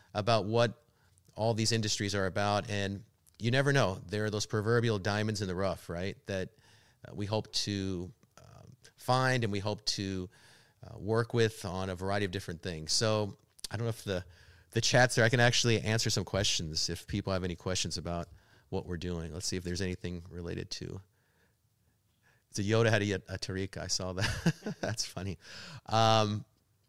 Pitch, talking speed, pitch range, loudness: 105 Hz, 190 wpm, 95-115 Hz, -32 LUFS